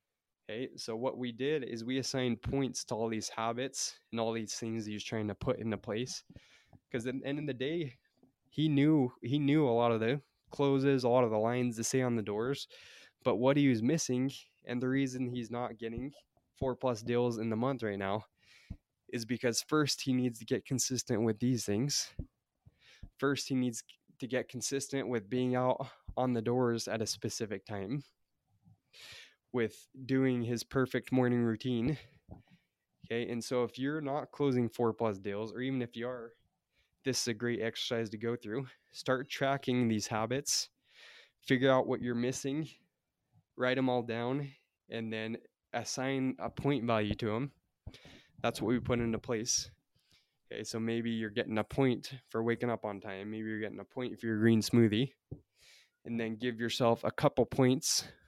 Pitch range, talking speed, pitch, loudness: 115-130 Hz, 185 wpm, 125 Hz, -34 LUFS